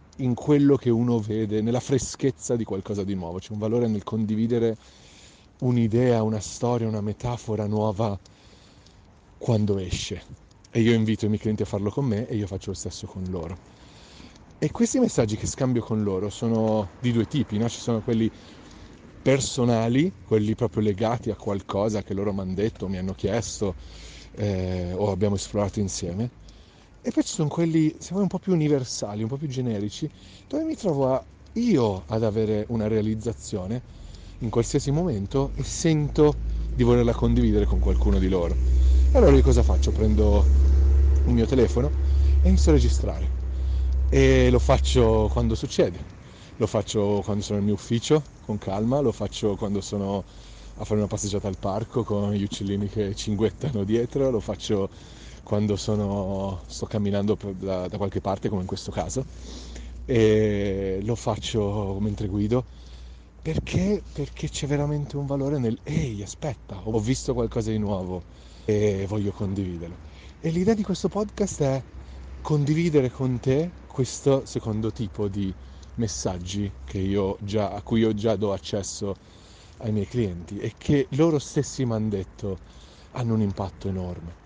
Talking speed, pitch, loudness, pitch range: 160 wpm, 105 Hz, -25 LUFS, 95-120 Hz